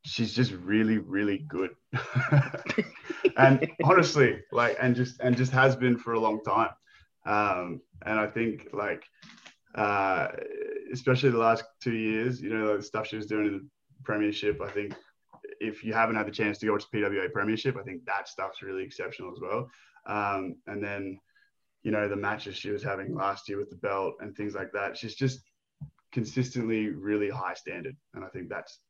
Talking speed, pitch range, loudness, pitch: 185 wpm, 105-130 Hz, -29 LUFS, 110 Hz